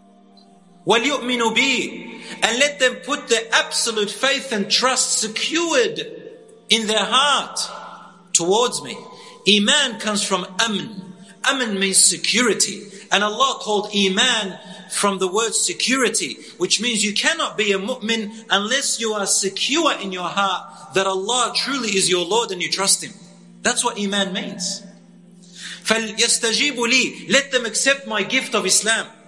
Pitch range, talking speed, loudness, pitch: 195-255 Hz, 135 wpm, -18 LUFS, 220 Hz